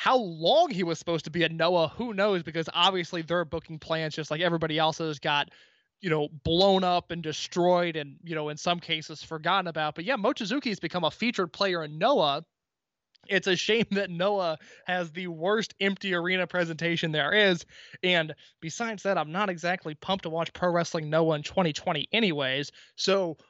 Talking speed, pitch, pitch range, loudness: 185 wpm, 175 Hz, 160-195 Hz, -27 LUFS